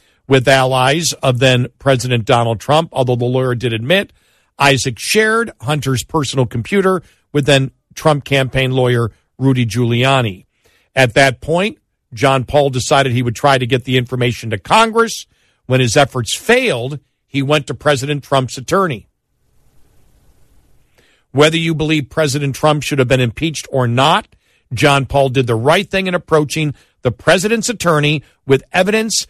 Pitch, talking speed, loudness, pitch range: 135 Hz, 150 wpm, -14 LUFS, 125-150 Hz